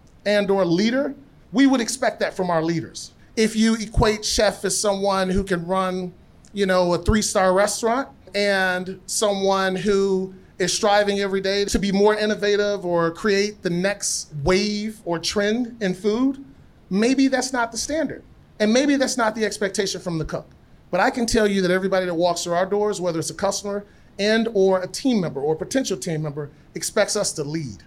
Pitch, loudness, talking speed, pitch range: 200 Hz, -21 LUFS, 185 wpm, 185-215 Hz